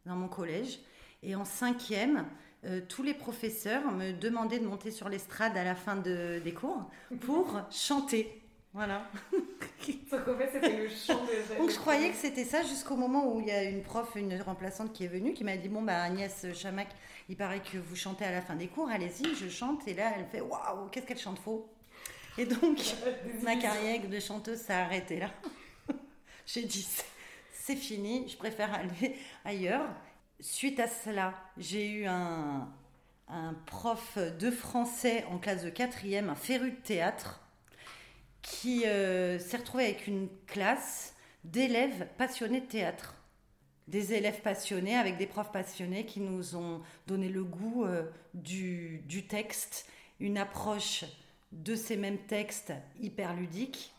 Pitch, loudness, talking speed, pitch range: 210 Hz, -35 LUFS, 160 wpm, 190-245 Hz